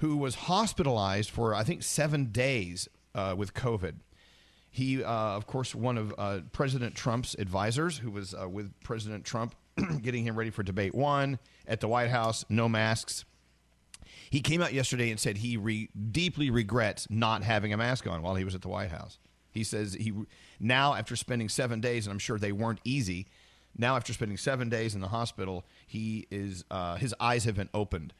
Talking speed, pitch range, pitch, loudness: 195 wpm, 100-125 Hz, 110 Hz, -32 LUFS